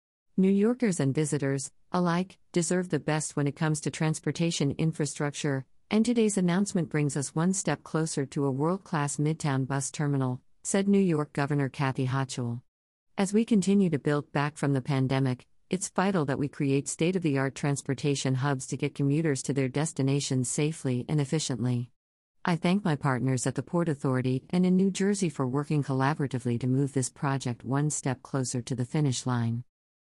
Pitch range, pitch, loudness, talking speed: 135-165 Hz, 145 Hz, -28 LUFS, 170 wpm